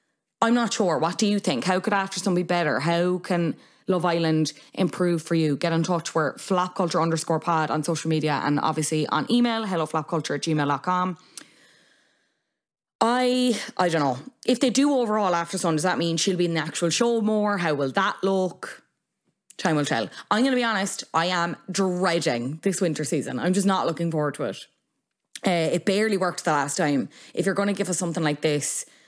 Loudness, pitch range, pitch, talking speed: -24 LUFS, 160-195 Hz, 175 Hz, 205 wpm